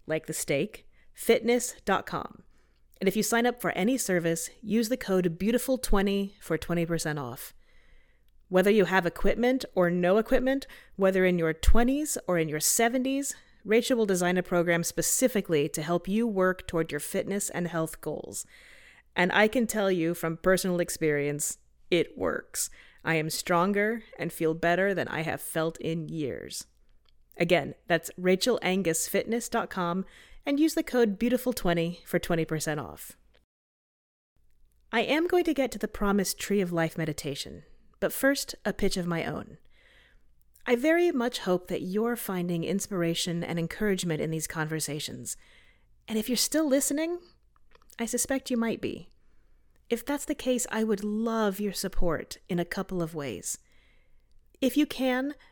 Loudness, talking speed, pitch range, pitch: -28 LUFS, 155 wpm, 165-235 Hz, 185 Hz